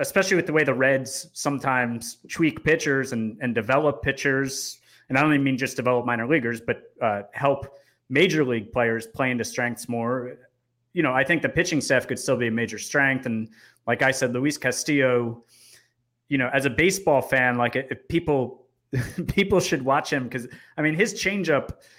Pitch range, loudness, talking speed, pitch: 120-145 Hz, -24 LUFS, 190 wpm, 130 Hz